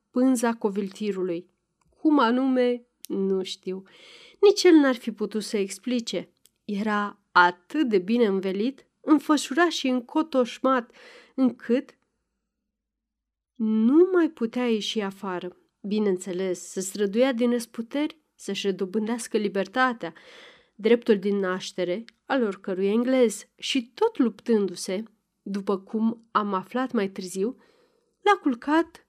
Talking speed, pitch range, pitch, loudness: 105 wpm, 195-260 Hz, 230 Hz, -25 LUFS